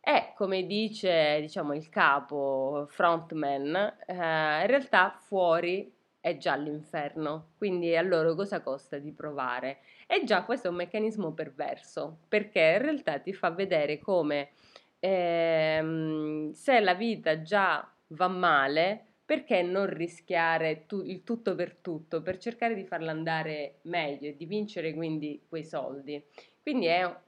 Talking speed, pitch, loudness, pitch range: 140 wpm, 170 Hz, -29 LUFS, 155-195 Hz